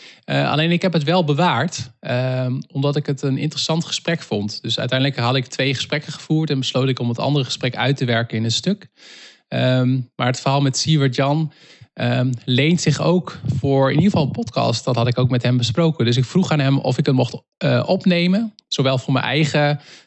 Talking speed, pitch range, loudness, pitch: 220 wpm, 125-155 Hz, -19 LUFS, 135 Hz